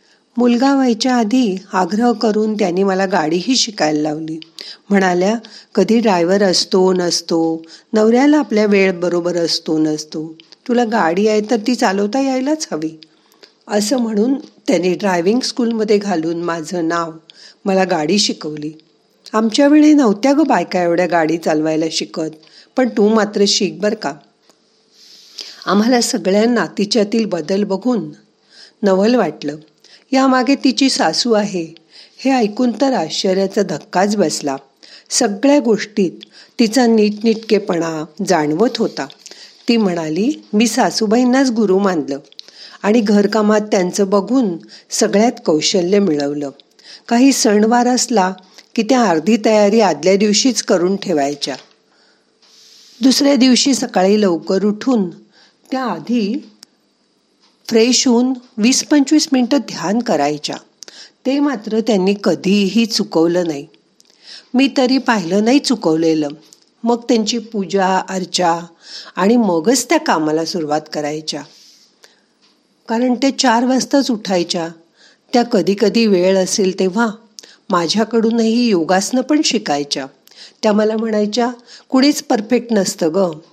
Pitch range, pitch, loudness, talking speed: 175-240 Hz, 210 Hz, -15 LUFS, 115 wpm